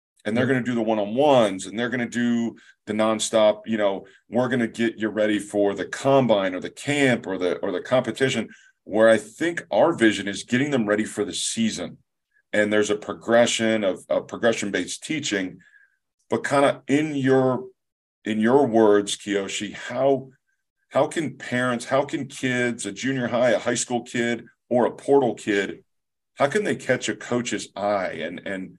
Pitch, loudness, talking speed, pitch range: 115 Hz, -23 LUFS, 185 wpm, 105-130 Hz